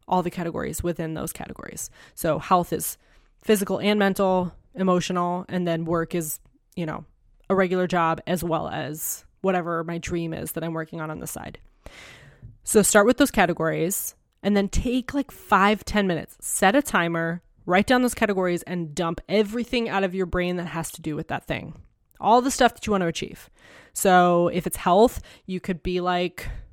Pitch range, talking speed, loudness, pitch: 165-200 Hz, 190 wpm, -24 LUFS, 180 Hz